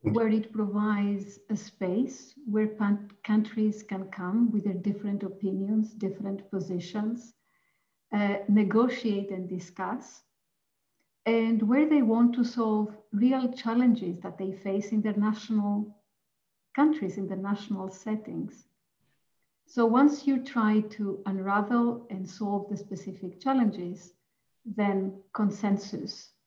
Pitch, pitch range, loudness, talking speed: 210 Hz, 195-225 Hz, -29 LUFS, 120 wpm